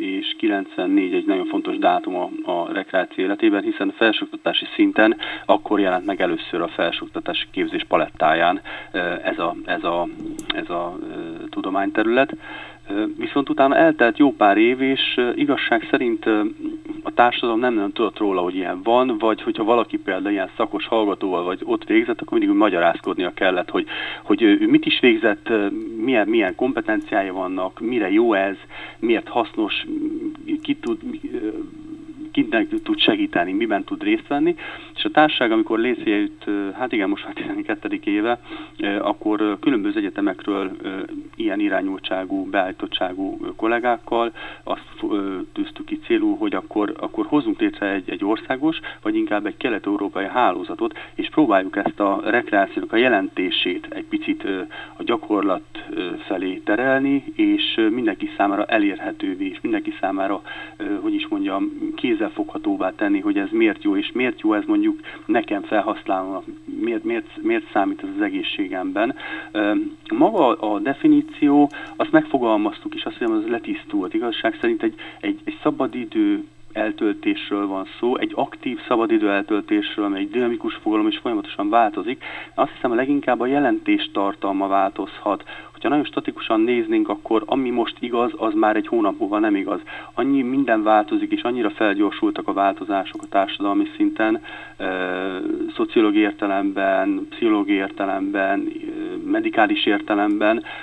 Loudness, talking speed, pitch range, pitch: -21 LUFS, 140 wpm, 310-335 Hz, 320 Hz